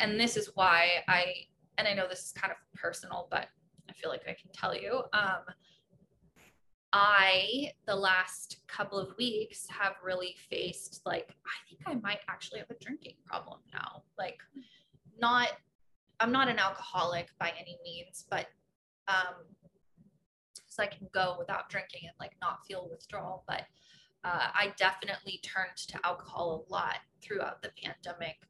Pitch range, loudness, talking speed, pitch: 180-205 Hz, -33 LUFS, 160 wpm, 190 Hz